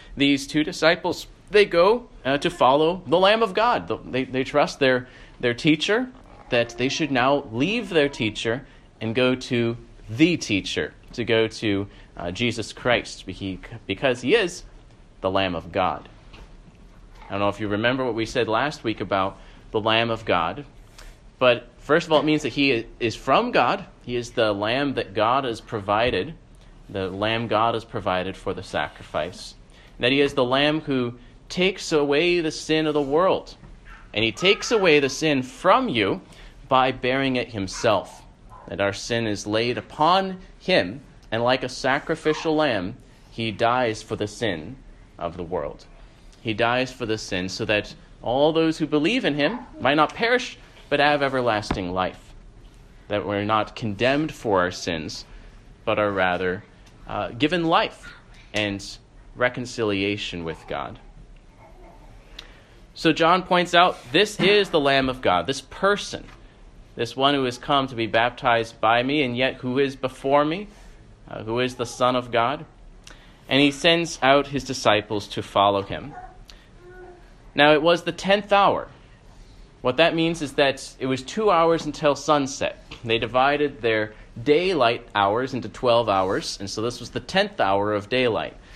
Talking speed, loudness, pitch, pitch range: 165 wpm, -22 LUFS, 125 Hz, 110-150 Hz